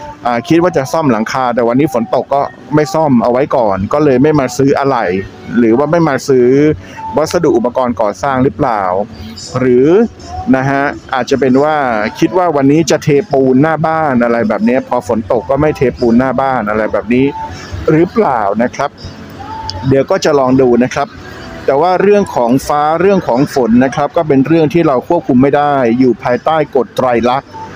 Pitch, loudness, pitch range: 140 Hz, -11 LUFS, 125-155 Hz